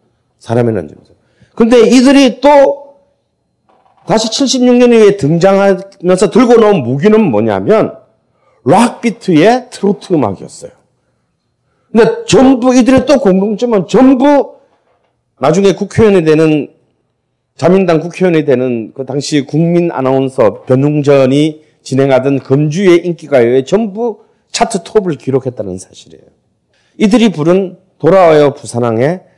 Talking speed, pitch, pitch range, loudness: 270 characters per minute, 185 Hz, 140-230 Hz, -9 LUFS